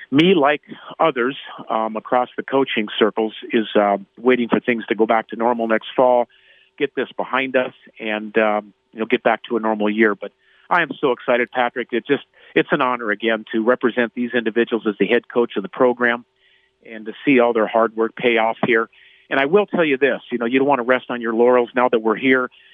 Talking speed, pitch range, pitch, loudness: 230 wpm, 110-125 Hz, 115 Hz, -19 LUFS